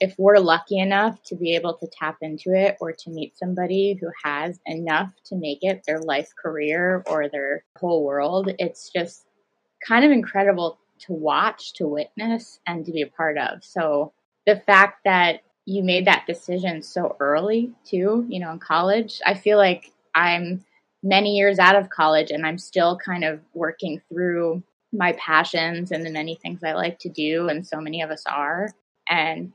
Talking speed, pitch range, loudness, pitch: 185 wpm, 160-195 Hz, -22 LUFS, 175 Hz